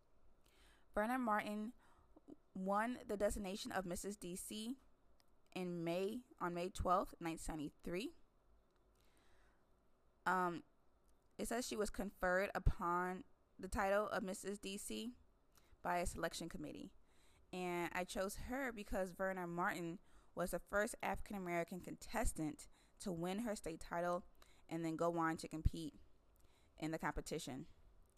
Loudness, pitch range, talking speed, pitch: -44 LUFS, 170-210 Hz, 120 wpm, 185 Hz